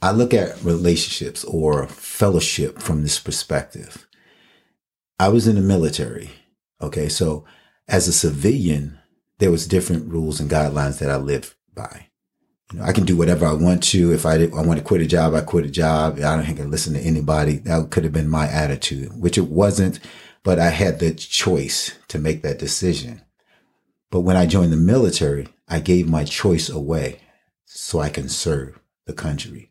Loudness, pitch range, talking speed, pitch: -19 LUFS, 75-90 Hz, 190 wpm, 80 Hz